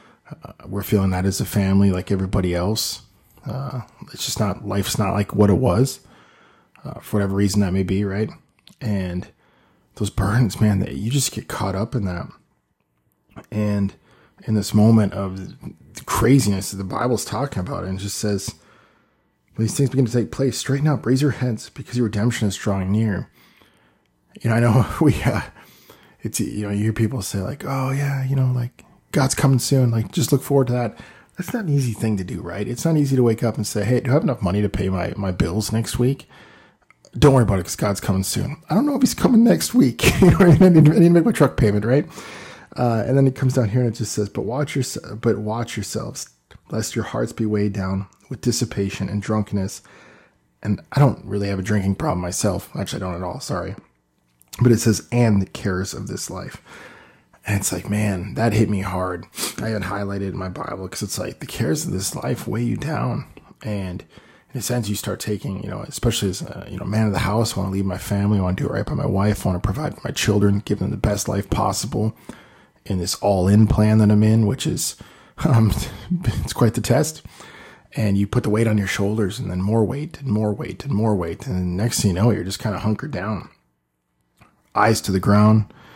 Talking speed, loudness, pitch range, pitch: 230 wpm, -21 LUFS, 100-125 Hz, 105 Hz